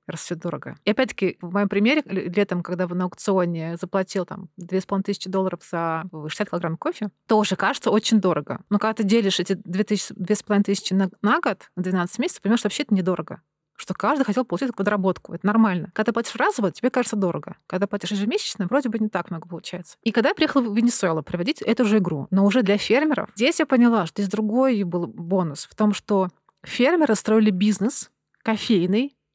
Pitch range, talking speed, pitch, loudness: 180-220 Hz, 190 wpm, 200 Hz, -23 LUFS